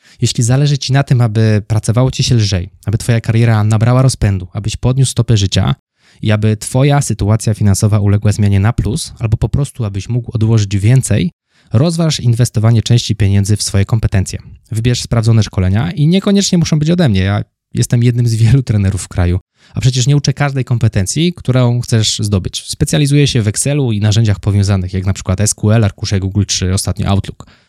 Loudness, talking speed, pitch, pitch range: -13 LUFS, 180 wpm, 115 Hz, 105-125 Hz